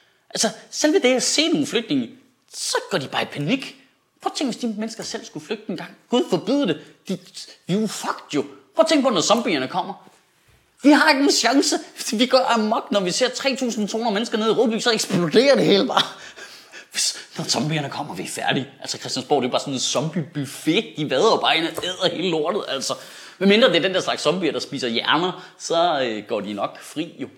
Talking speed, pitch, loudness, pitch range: 220 wpm, 230 Hz, -21 LUFS, 190-270 Hz